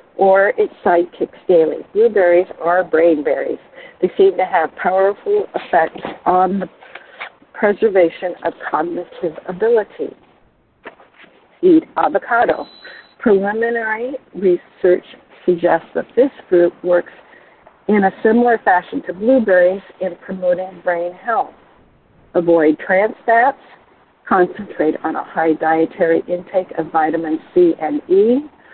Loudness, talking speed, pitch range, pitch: -16 LUFS, 110 wpm, 175-235 Hz, 185 Hz